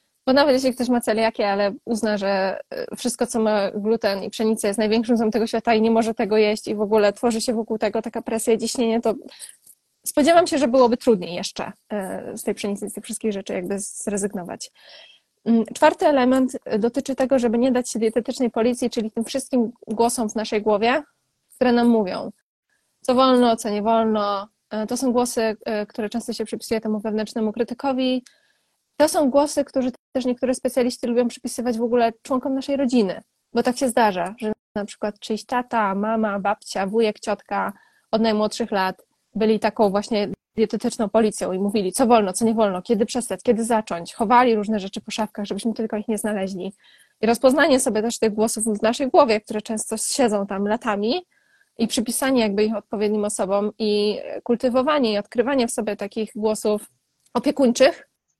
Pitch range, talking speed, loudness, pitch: 215-245 Hz, 180 wpm, -22 LUFS, 225 Hz